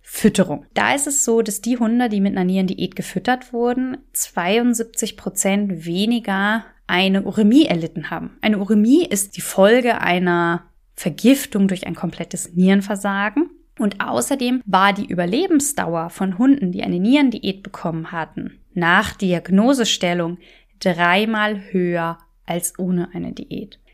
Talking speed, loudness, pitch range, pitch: 130 wpm, -19 LUFS, 180-230 Hz, 200 Hz